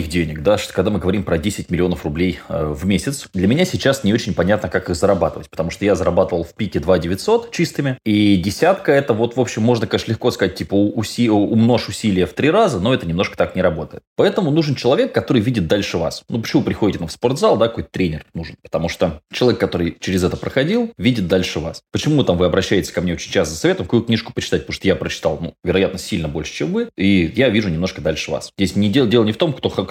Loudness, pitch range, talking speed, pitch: -18 LUFS, 90-120 Hz, 245 wpm, 105 Hz